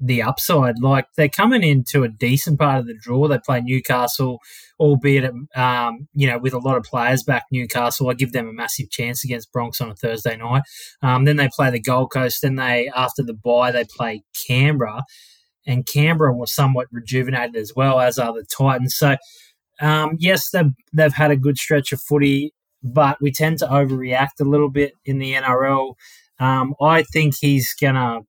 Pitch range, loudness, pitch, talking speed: 125-145 Hz, -19 LUFS, 130 Hz, 195 wpm